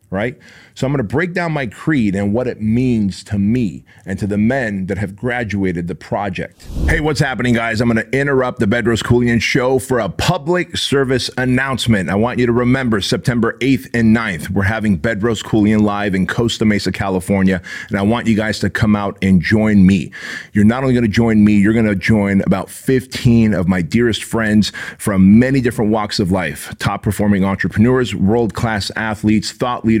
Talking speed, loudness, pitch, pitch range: 200 wpm, -16 LUFS, 110 Hz, 100-125 Hz